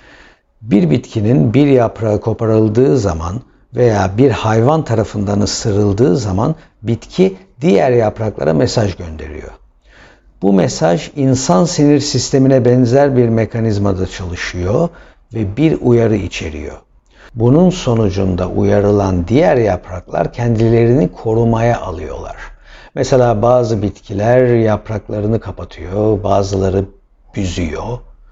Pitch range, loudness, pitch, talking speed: 100-125 Hz, -14 LUFS, 110 Hz, 95 wpm